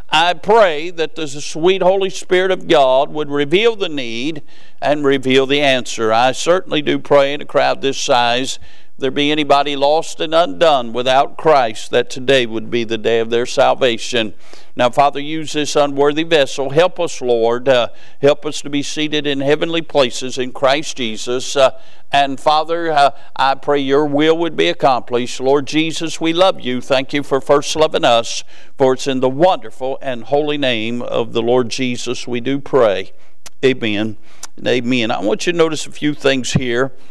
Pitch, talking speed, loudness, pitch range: 140 Hz, 180 wpm, -16 LUFS, 125-150 Hz